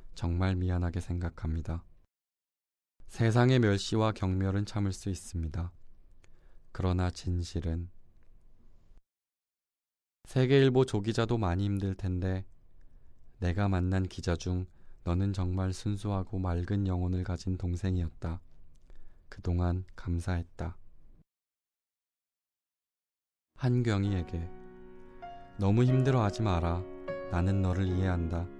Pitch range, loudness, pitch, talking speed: 85-100 Hz, -31 LUFS, 90 Hz, 215 characters per minute